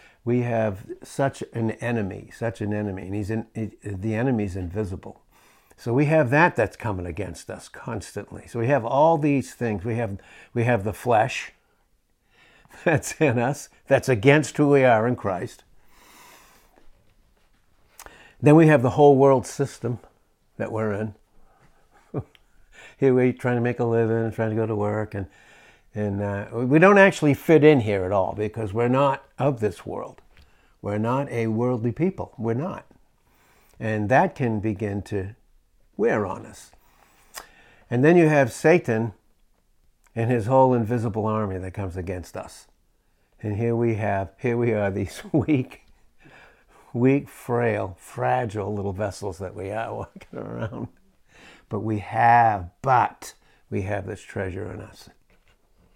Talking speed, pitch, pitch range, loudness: 155 wpm, 110 Hz, 100-125 Hz, -23 LUFS